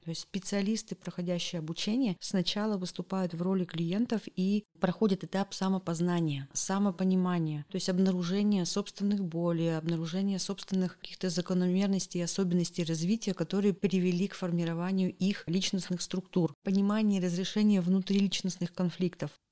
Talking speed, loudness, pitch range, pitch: 120 wpm, -31 LUFS, 175-195 Hz, 185 Hz